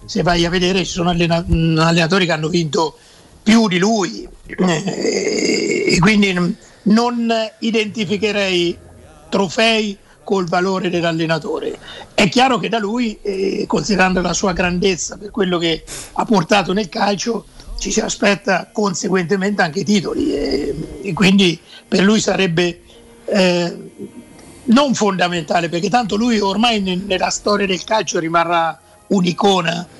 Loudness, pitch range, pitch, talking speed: -17 LUFS, 175-215 Hz, 195 Hz, 120 wpm